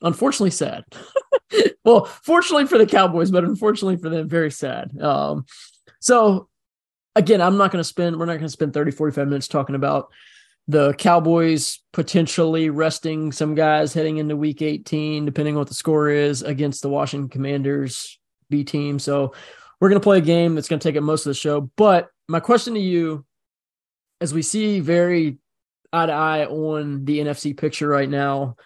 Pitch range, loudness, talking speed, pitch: 145-175 Hz, -20 LUFS, 180 wpm, 155 Hz